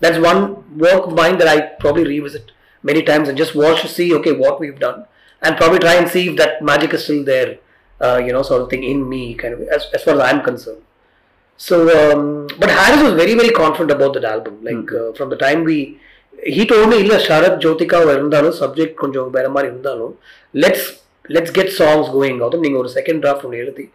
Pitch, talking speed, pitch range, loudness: 155 Hz, 190 wpm, 140-170 Hz, -14 LUFS